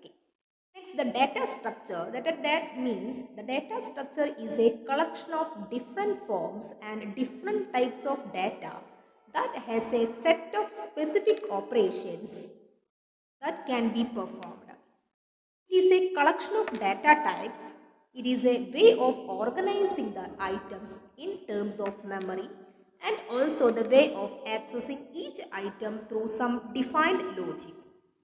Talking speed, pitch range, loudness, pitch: 130 wpm, 220-325 Hz, -28 LUFS, 255 Hz